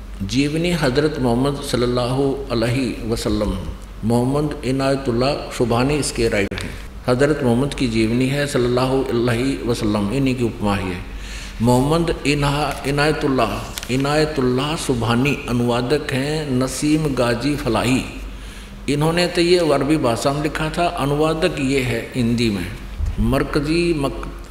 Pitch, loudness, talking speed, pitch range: 130 Hz, -19 LUFS, 115 wpm, 115-145 Hz